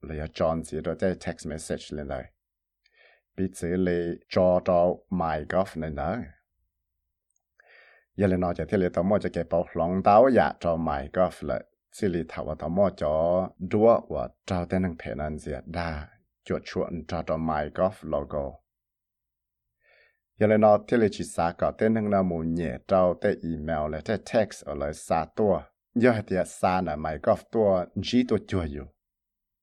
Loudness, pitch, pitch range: -26 LUFS, 85 Hz, 80-95 Hz